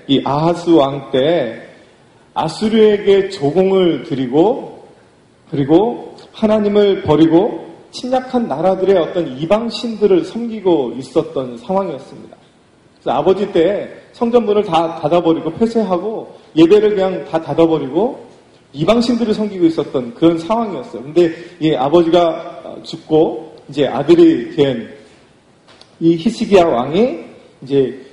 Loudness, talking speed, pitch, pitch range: -15 LUFS, 275 characters per minute, 175 Hz, 160-215 Hz